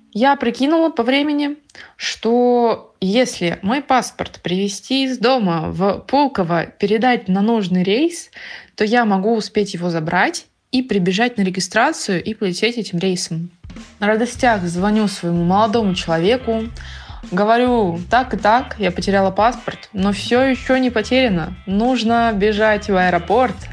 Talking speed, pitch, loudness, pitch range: 135 wpm, 215 Hz, -17 LUFS, 190-245 Hz